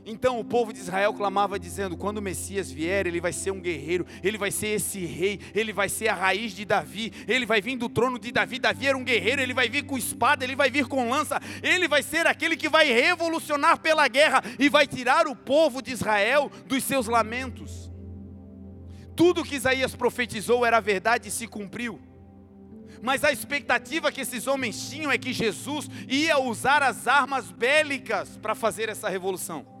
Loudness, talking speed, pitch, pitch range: -24 LUFS, 195 wpm, 240 Hz, 205-280 Hz